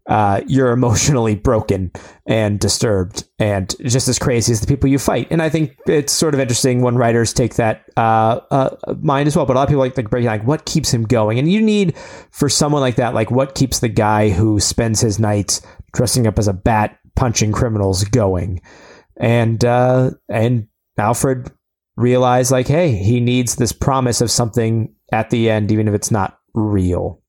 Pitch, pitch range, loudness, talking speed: 120 Hz, 110-130 Hz, -16 LUFS, 195 wpm